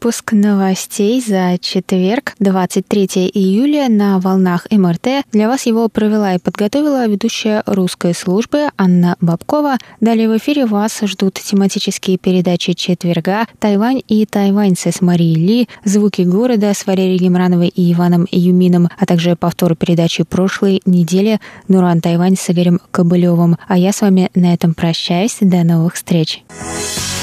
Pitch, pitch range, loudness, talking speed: 190 Hz, 175-210 Hz, -13 LUFS, 140 wpm